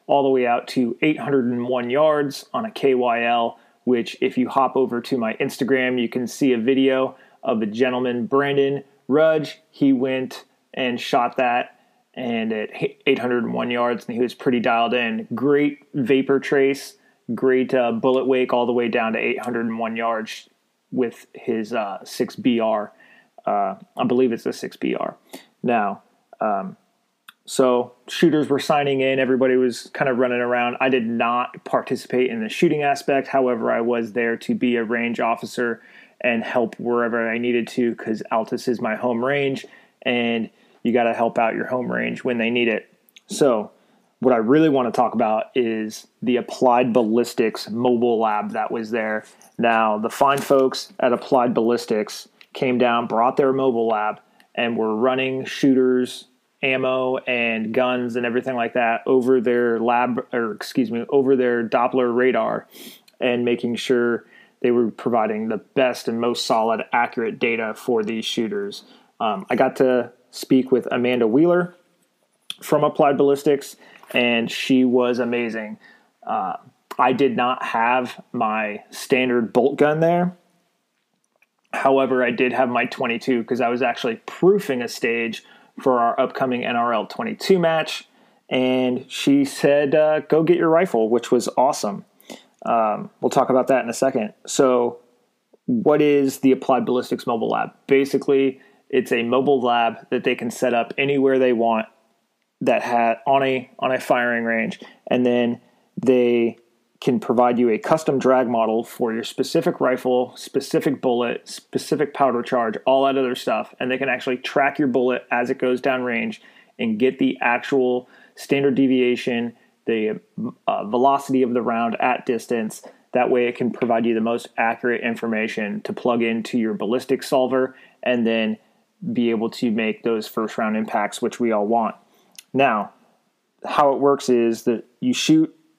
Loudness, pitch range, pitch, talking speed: -21 LUFS, 120-135 Hz, 125 Hz, 165 wpm